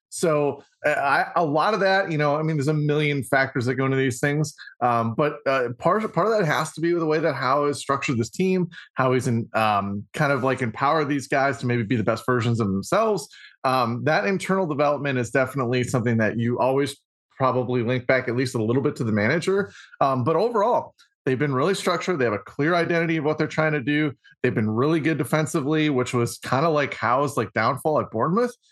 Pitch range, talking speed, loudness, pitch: 125-155 Hz, 235 wpm, -23 LUFS, 140 Hz